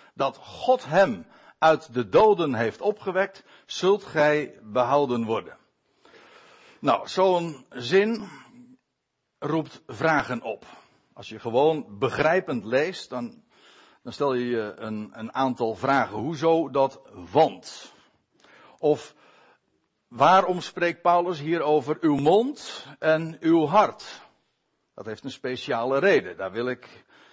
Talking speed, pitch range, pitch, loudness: 120 wpm, 125-190 Hz, 155 Hz, -24 LUFS